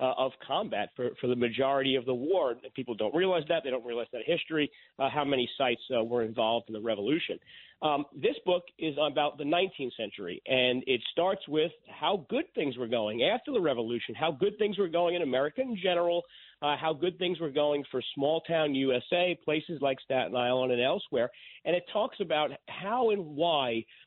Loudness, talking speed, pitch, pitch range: -30 LUFS, 200 wpm, 150 Hz, 130-175 Hz